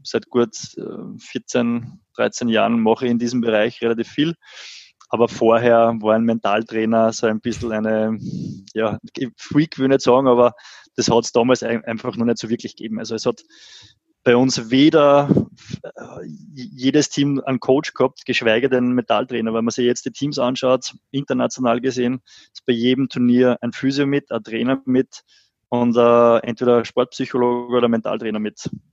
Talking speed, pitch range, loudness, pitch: 170 wpm, 115-130 Hz, -19 LUFS, 120 Hz